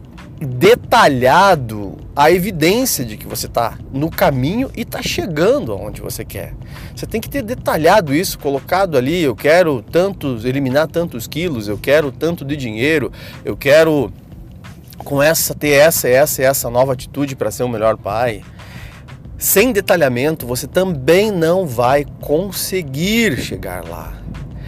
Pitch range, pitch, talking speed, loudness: 125-170 Hz, 140 Hz, 145 wpm, -15 LUFS